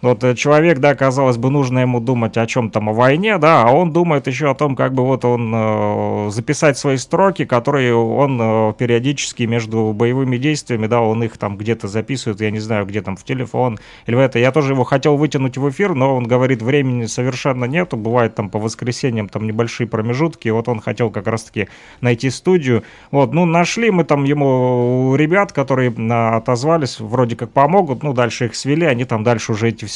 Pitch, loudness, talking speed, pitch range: 125 Hz, -16 LUFS, 200 wpm, 115-140 Hz